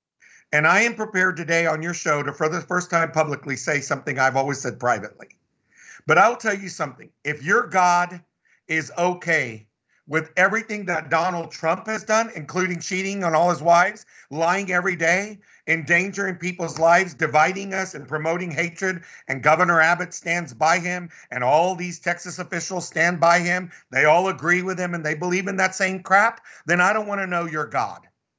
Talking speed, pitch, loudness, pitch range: 185 wpm, 175 Hz, -21 LUFS, 160-185 Hz